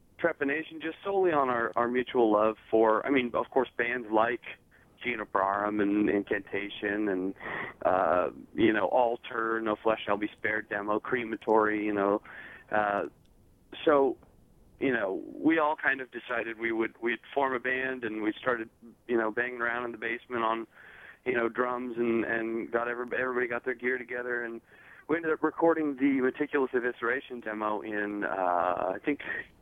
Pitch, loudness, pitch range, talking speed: 120 Hz, -29 LUFS, 110-130 Hz, 170 wpm